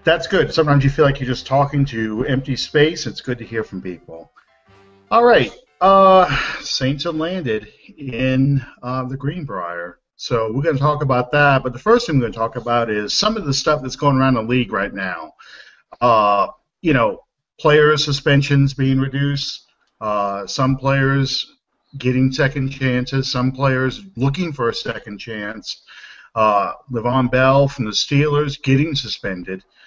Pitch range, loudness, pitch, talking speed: 120-145 Hz, -18 LUFS, 135 Hz, 170 wpm